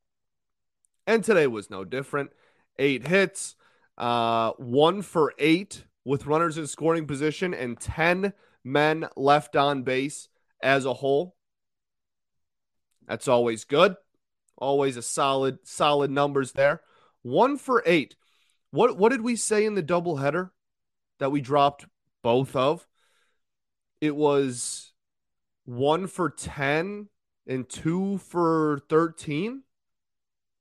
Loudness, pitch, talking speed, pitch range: -25 LUFS, 145 Hz, 120 wpm, 125-165 Hz